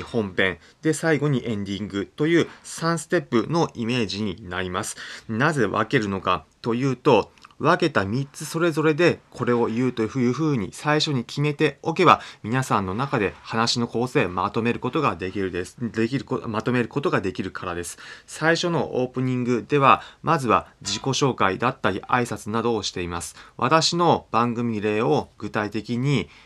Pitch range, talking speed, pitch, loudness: 105-145 Hz, 310 characters per minute, 120 Hz, -23 LUFS